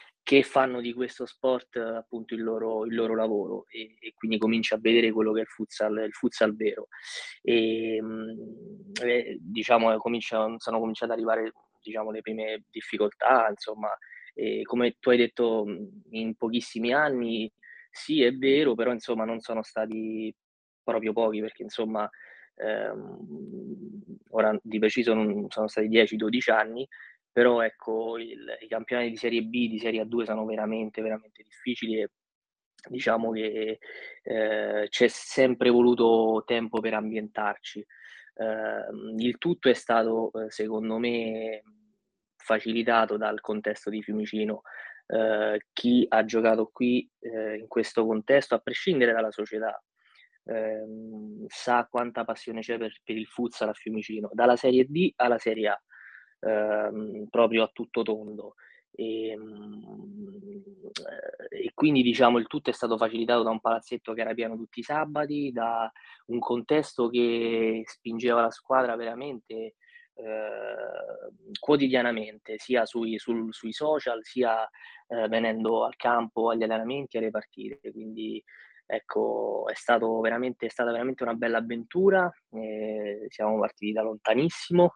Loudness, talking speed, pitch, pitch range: -27 LUFS, 135 wpm, 115 Hz, 110-120 Hz